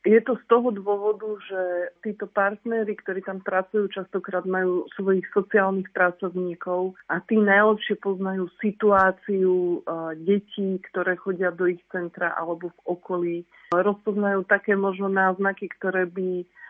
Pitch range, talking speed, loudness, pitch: 180-205 Hz, 130 wpm, -24 LUFS, 190 Hz